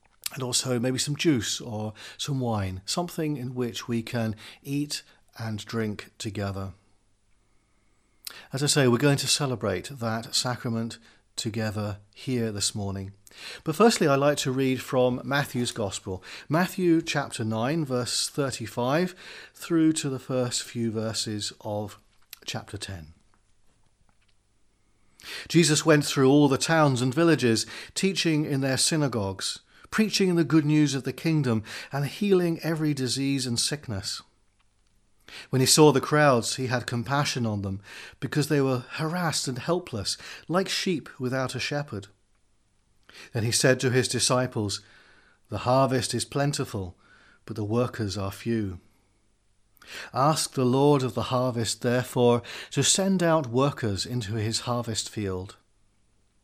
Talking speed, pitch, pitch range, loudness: 135 wpm, 125 Hz, 105-145 Hz, -26 LUFS